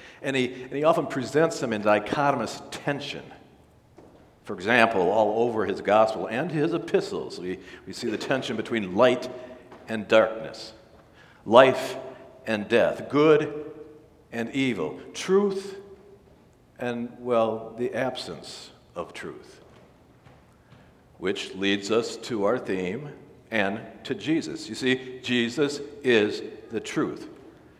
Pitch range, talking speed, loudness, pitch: 110-150 Hz, 120 wpm, -25 LUFS, 125 Hz